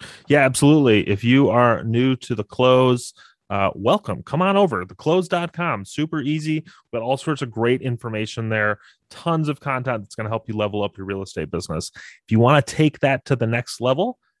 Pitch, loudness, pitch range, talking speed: 130 Hz, -20 LUFS, 110-150 Hz, 205 wpm